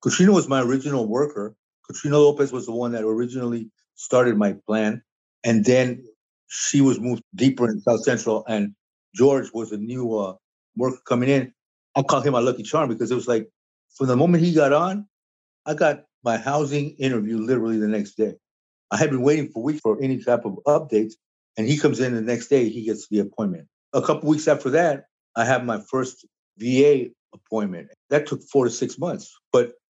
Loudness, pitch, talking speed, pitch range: -22 LUFS, 125 Hz, 200 wpm, 110-145 Hz